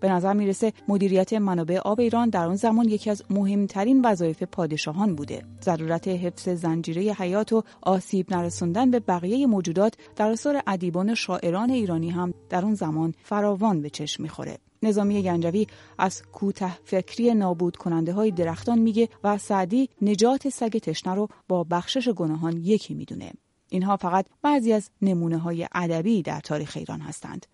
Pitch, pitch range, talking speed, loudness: 190 Hz, 175-215 Hz, 155 wpm, -25 LUFS